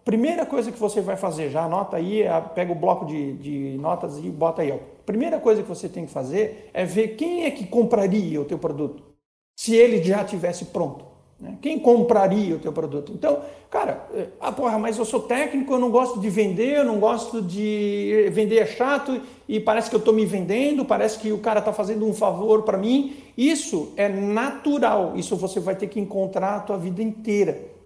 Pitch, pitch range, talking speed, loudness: 215 Hz, 190-235 Hz, 205 wpm, -23 LUFS